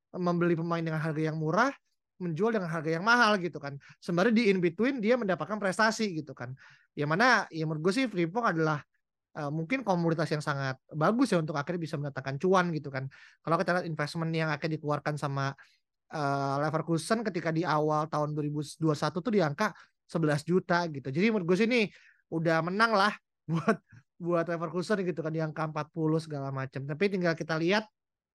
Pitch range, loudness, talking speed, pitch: 150-190 Hz, -29 LUFS, 180 wpm, 165 Hz